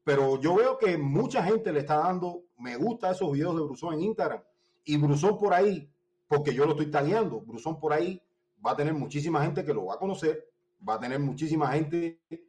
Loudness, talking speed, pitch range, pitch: -28 LUFS, 215 wpm, 145-180 Hz, 160 Hz